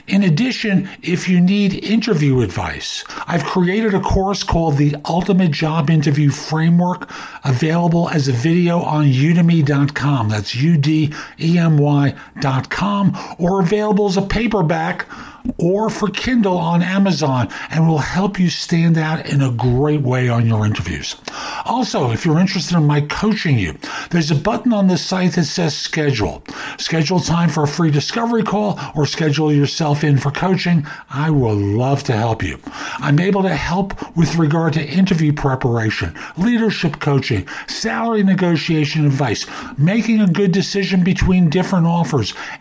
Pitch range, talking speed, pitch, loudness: 145-185 Hz, 155 wpm, 165 Hz, -17 LUFS